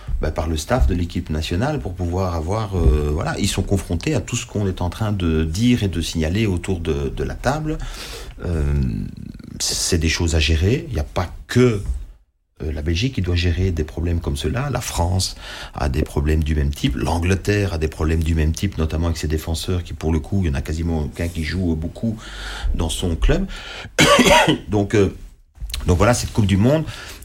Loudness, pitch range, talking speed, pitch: -20 LUFS, 80-100 Hz, 210 wpm, 85 Hz